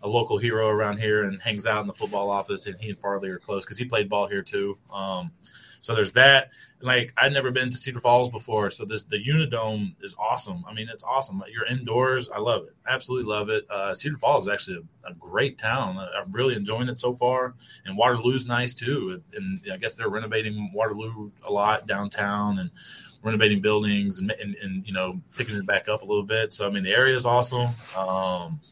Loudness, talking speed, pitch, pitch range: -25 LUFS, 225 wpm, 110 Hz, 100-130 Hz